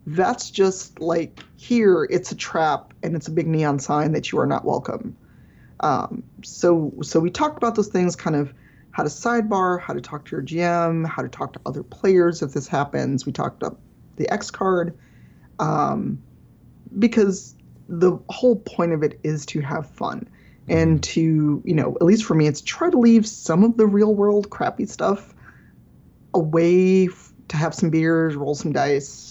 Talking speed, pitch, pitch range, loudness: 185 wpm, 170 Hz, 155-200 Hz, -21 LUFS